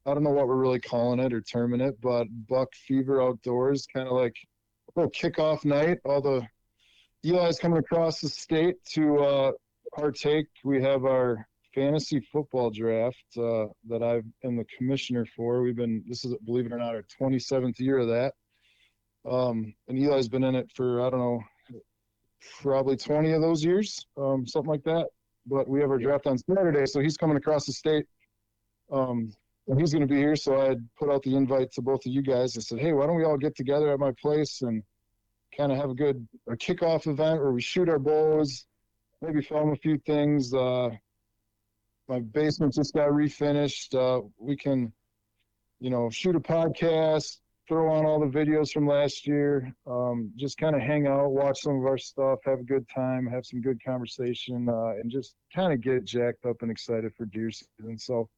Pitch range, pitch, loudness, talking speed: 120-145 Hz, 135 Hz, -27 LUFS, 200 wpm